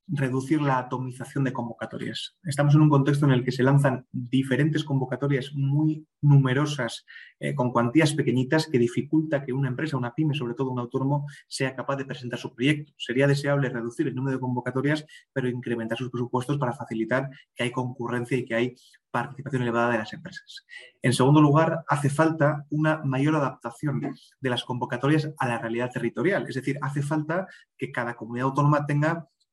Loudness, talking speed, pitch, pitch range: -26 LUFS, 175 wpm, 135 Hz, 125-145 Hz